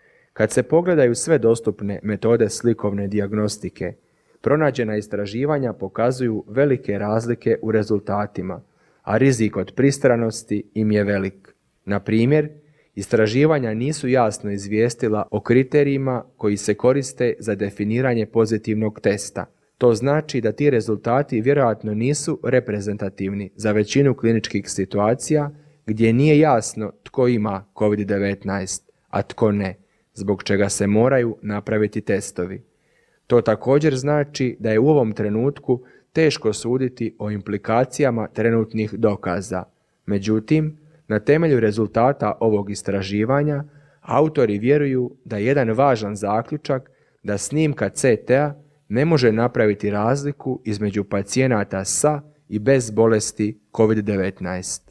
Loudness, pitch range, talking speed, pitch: -20 LUFS, 105-135 Hz, 115 wpm, 110 Hz